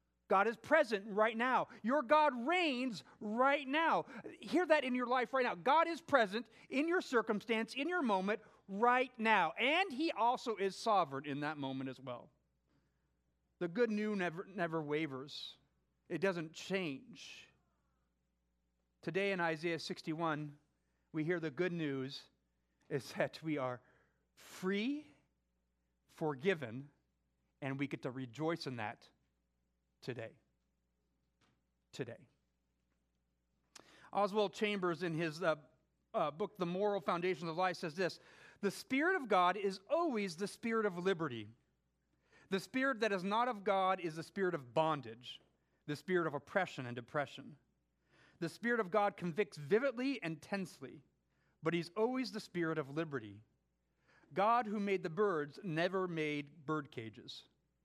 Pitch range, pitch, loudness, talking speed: 130-215 Hz, 170 Hz, -37 LUFS, 140 wpm